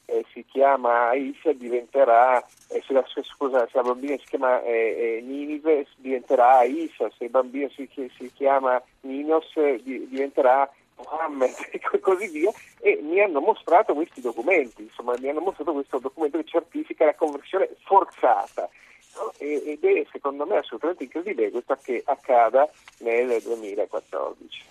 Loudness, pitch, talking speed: -24 LUFS, 150 Hz, 155 wpm